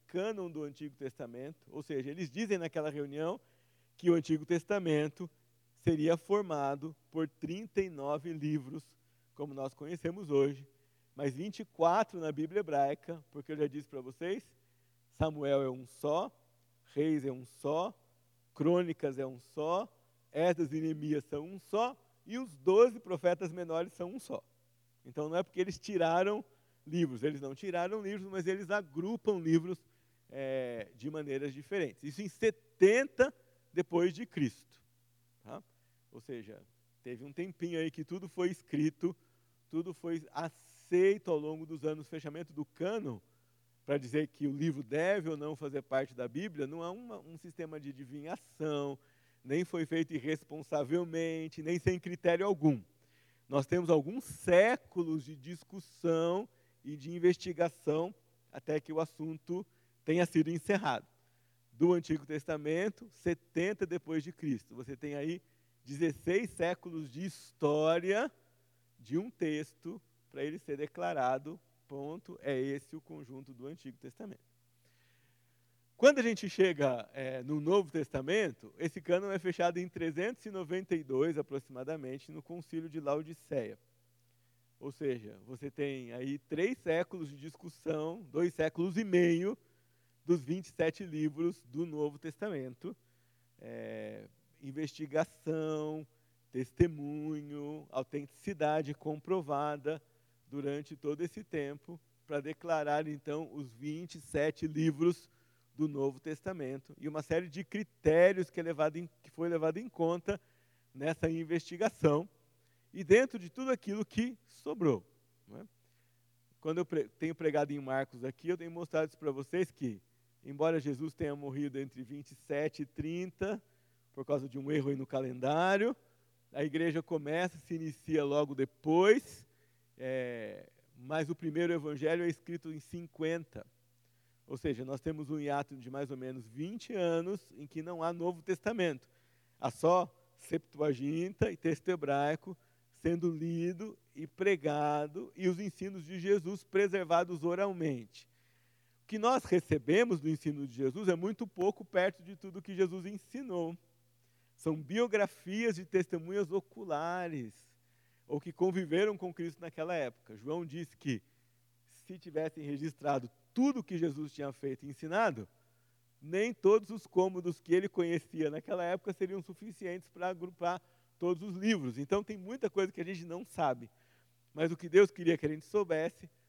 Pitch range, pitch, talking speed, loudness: 135-175 Hz, 155 Hz, 140 wpm, -35 LUFS